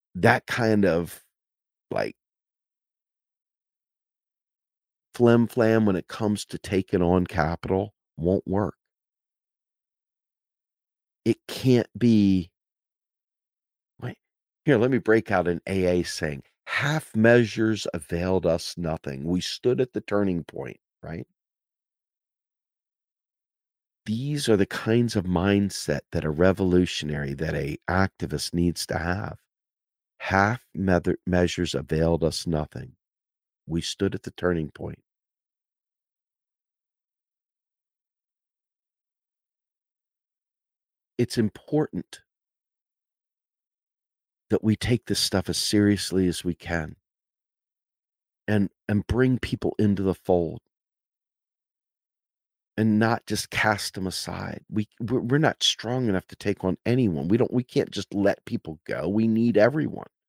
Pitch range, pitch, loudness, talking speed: 85-110 Hz, 95 Hz, -25 LUFS, 110 wpm